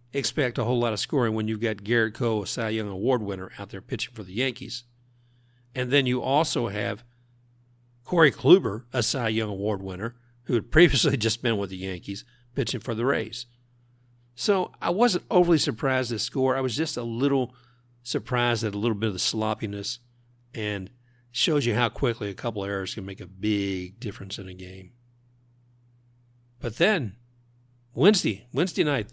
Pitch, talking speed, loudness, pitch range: 120 Hz, 185 wpm, -26 LUFS, 110-125 Hz